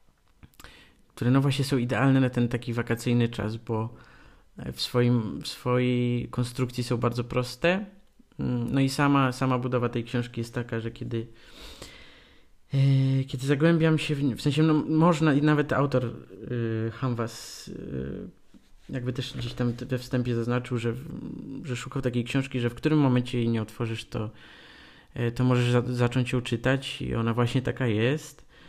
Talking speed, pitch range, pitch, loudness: 160 wpm, 120-135 Hz, 125 Hz, -27 LUFS